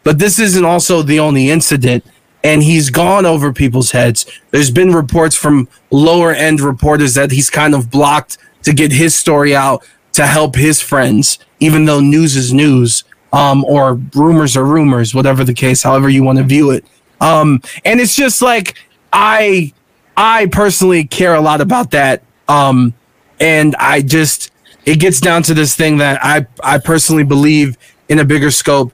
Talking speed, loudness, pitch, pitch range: 175 wpm, -10 LUFS, 150 Hz, 135-160 Hz